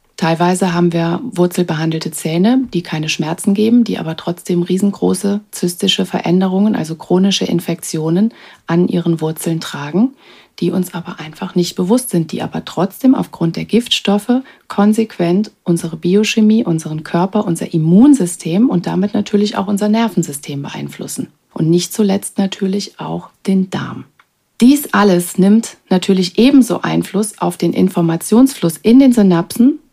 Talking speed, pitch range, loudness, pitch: 135 wpm, 170-210 Hz, -14 LUFS, 185 Hz